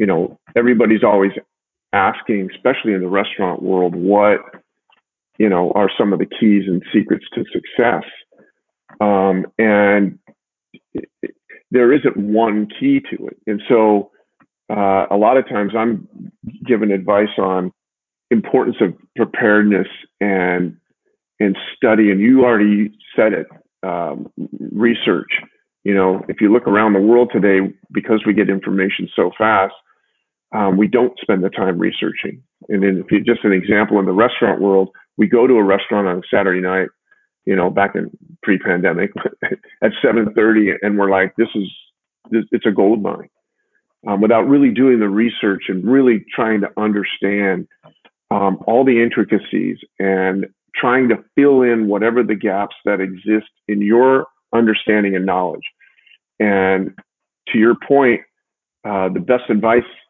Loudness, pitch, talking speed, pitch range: -16 LUFS, 105 Hz, 150 wpm, 95-115 Hz